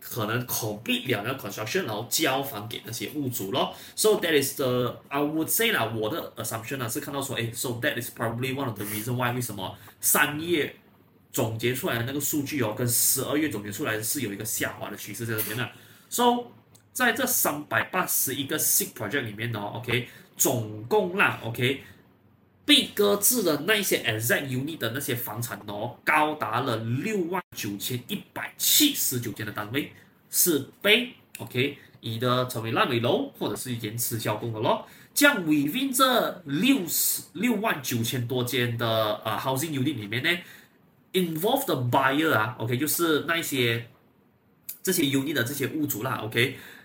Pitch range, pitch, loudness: 115-150 Hz, 125 Hz, -26 LUFS